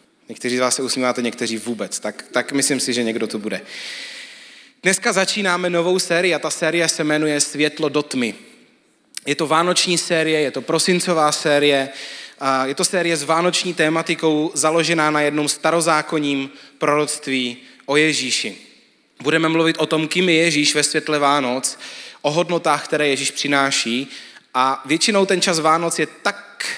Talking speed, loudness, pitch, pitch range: 155 wpm, -18 LUFS, 150 Hz, 135-165 Hz